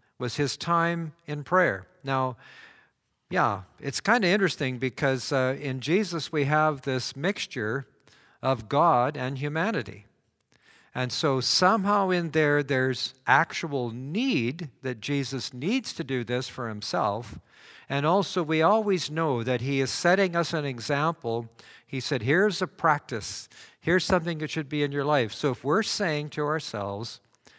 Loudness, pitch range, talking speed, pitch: -27 LUFS, 130-170 Hz, 150 wpm, 145 Hz